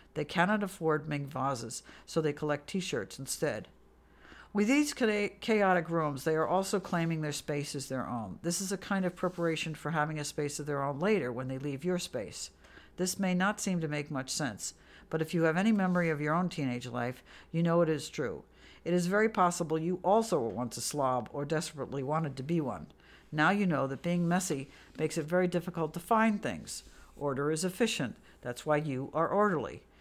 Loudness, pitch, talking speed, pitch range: -32 LUFS, 160 Hz, 205 wpm, 145-180 Hz